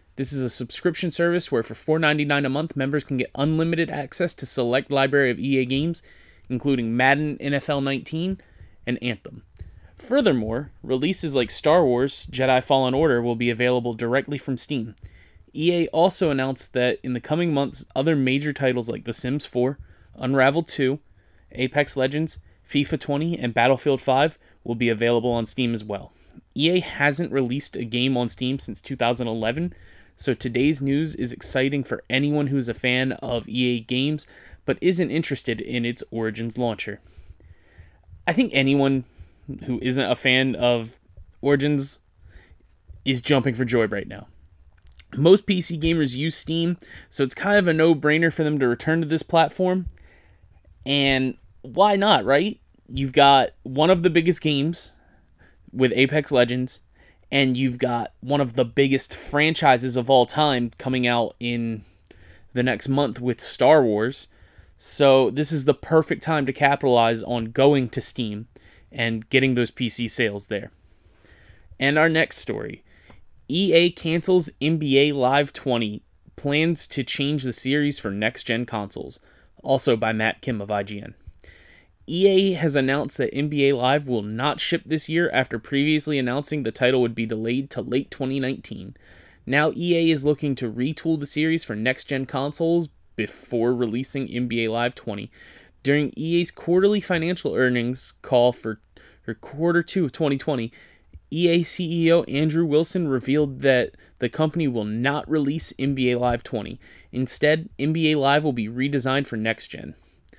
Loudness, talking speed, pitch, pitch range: -22 LUFS, 155 wpm, 130 Hz, 115-150 Hz